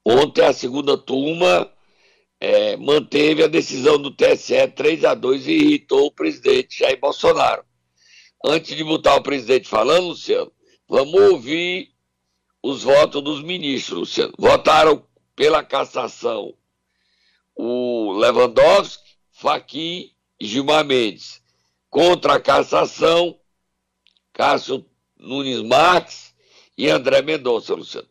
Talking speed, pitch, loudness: 110 wpm, 175 Hz, -18 LUFS